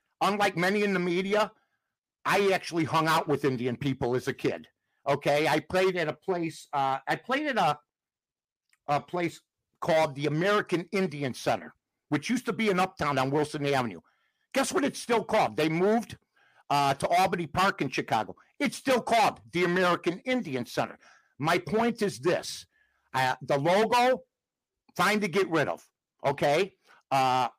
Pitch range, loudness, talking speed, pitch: 145-210 Hz, -28 LUFS, 165 wpm, 175 Hz